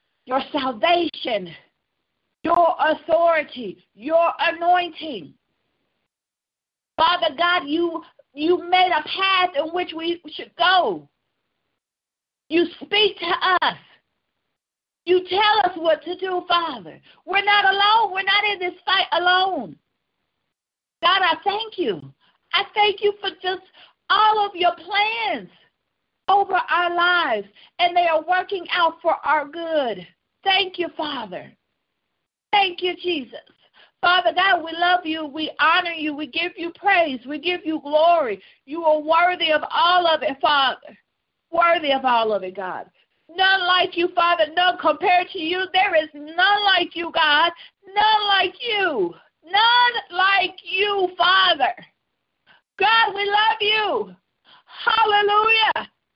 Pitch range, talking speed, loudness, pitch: 320-385 Hz, 130 wpm, -19 LUFS, 355 Hz